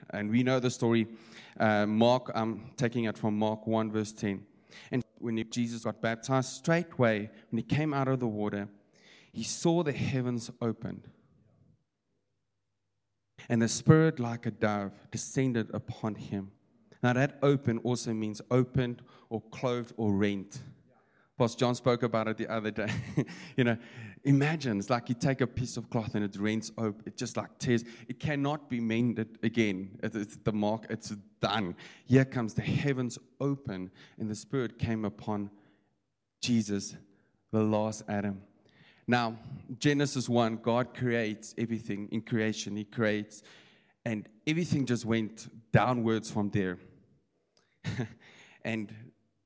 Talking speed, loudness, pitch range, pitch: 145 wpm, -31 LUFS, 105-125 Hz, 115 Hz